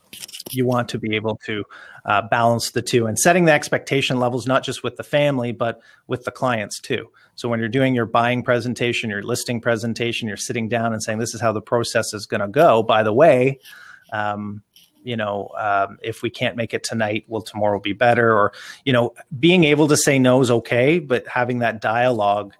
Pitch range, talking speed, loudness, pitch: 110-125 Hz, 220 wpm, -20 LUFS, 120 Hz